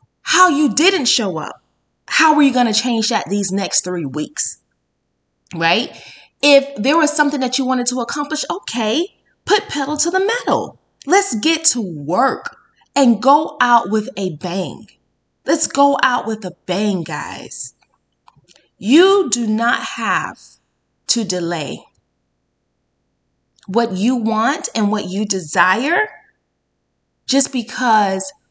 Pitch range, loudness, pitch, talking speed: 200-295 Hz, -16 LUFS, 245 Hz, 135 wpm